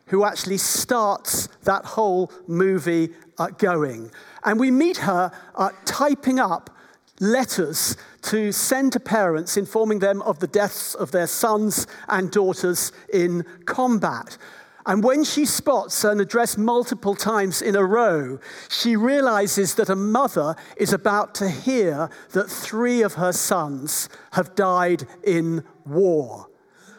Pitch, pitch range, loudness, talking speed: 200 Hz, 180-225 Hz, -21 LUFS, 130 wpm